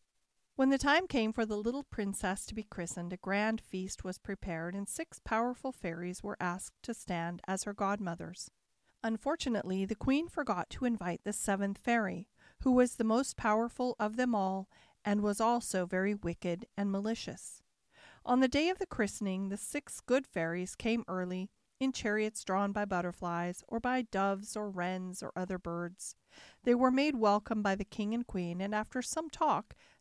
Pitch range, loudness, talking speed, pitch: 185-240 Hz, -34 LUFS, 180 wpm, 210 Hz